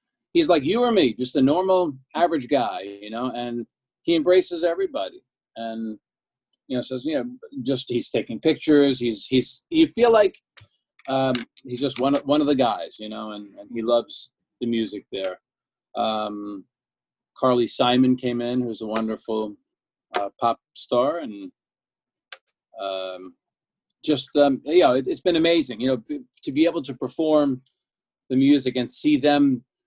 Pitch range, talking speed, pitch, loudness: 120-155 Hz, 170 wpm, 130 Hz, -22 LUFS